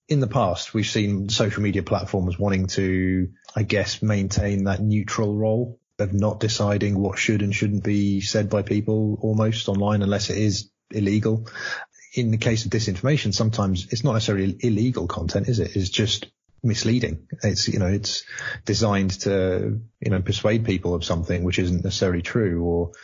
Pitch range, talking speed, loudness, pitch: 95-110 Hz, 170 wpm, -23 LUFS, 105 Hz